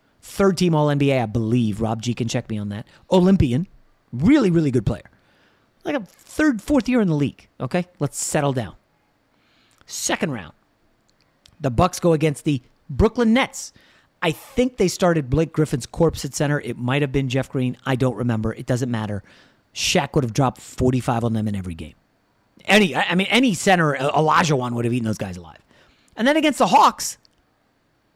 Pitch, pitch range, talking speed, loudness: 140 Hz, 120-180 Hz, 190 wpm, -20 LUFS